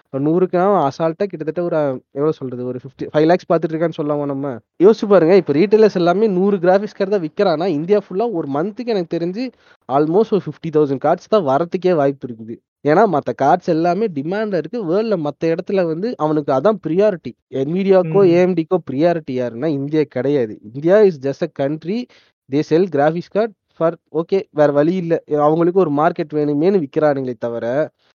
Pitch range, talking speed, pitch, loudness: 145-195 Hz, 160 wpm, 165 Hz, -17 LUFS